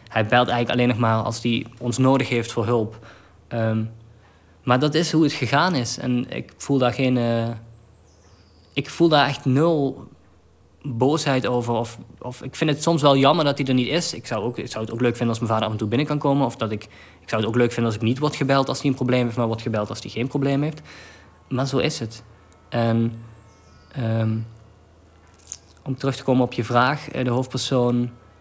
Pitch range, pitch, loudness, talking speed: 110-130 Hz, 120 Hz, -22 LUFS, 230 wpm